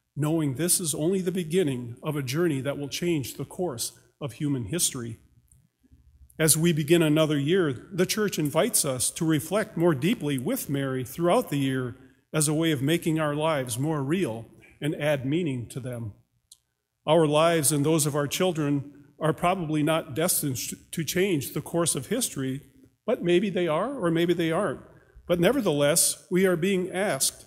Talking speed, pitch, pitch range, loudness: 175 wpm, 155 Hz, 140-175 Hz, -25 LUFS